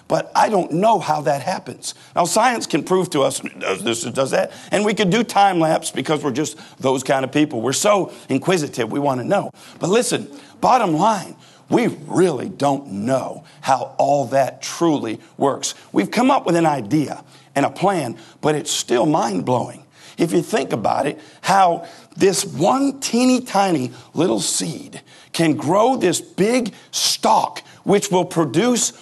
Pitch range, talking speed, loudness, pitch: 140-200 Hz, 175 wpm, -19 LUFS, 160 Hz